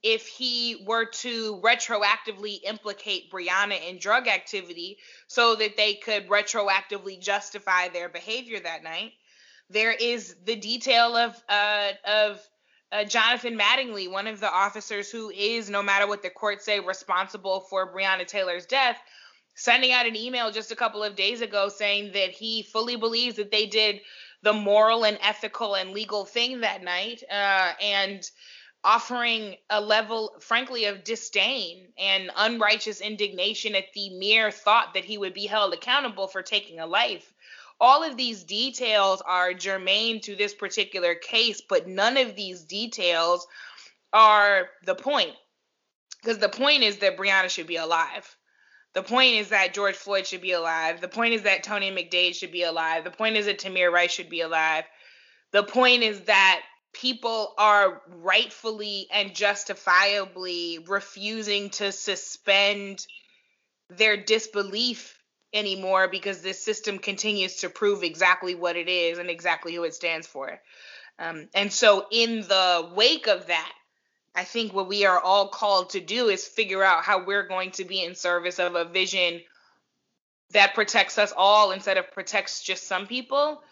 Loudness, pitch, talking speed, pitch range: -24 LUFS, 205 Hz, 160 wpm, 190-220 Hz